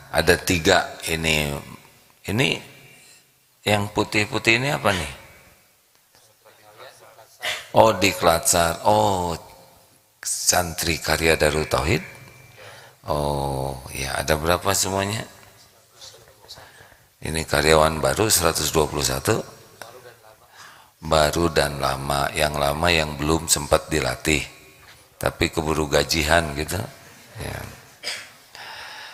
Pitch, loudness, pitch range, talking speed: 80 Hz, -21 LUFS, 75-90 Hz, 80 wpm